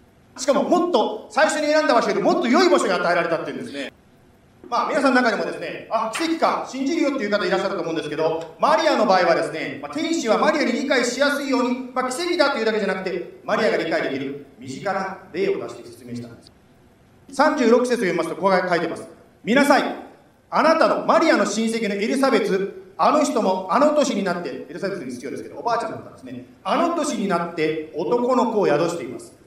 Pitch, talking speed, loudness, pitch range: 230 Hz, 460 characters per minute, -21 LUFS, 185-290 Hz